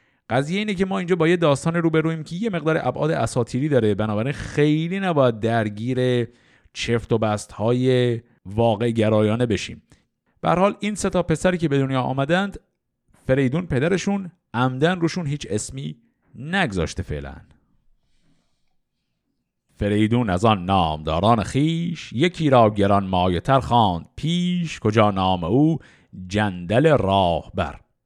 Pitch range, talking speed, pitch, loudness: 105-160 Hz, 125 wpm, 125 Hz, -21 LUFS